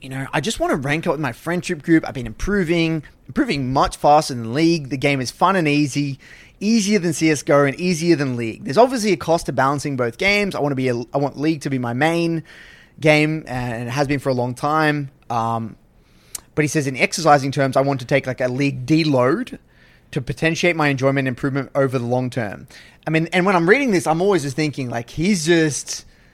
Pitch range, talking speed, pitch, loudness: 130-165 Hz, 230 wpm, 145 Hz, -19 LUFS